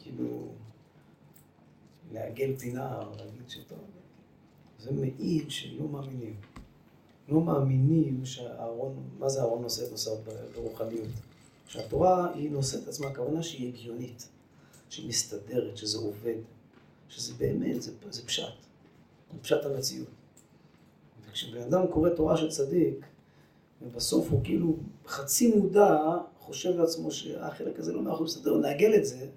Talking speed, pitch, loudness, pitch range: 120 wpm, 135 Hz, -30 LUFS, 115-160 Hz